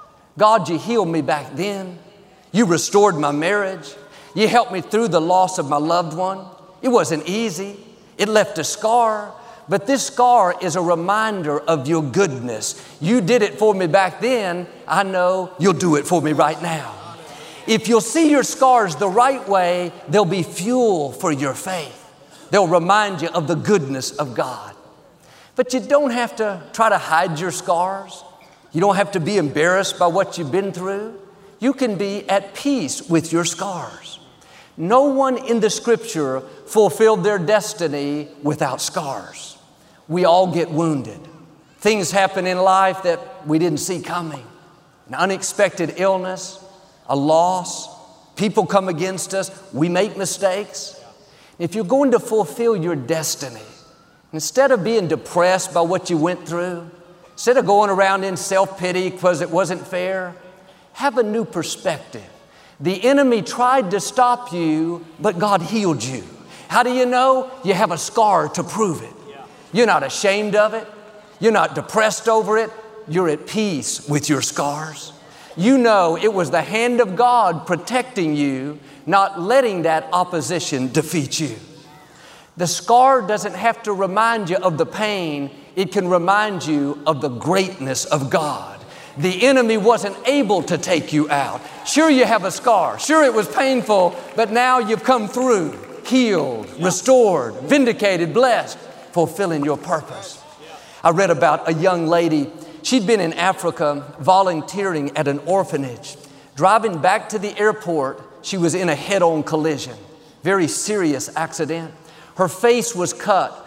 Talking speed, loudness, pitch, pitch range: 160 wpm, -18 LUFS, 185 Hz, 165-215 Hz